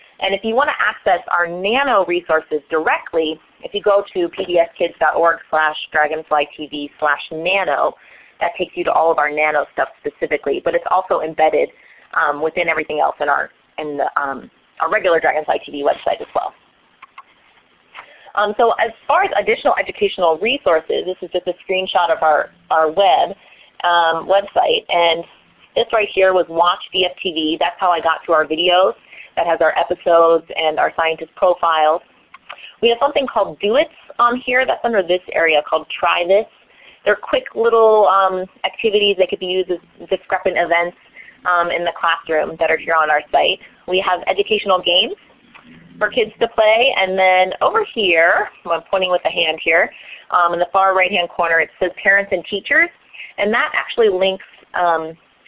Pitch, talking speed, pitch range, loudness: 180 Hz, 175 wpm, 160-200 Hz, -17 LUFS